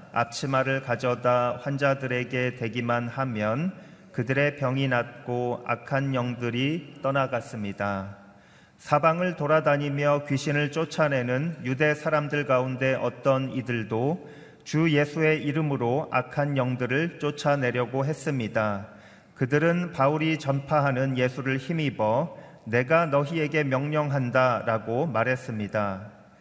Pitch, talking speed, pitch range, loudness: 135 Hz, 270 characters per minute, 120-150 Hz, -26 LUFS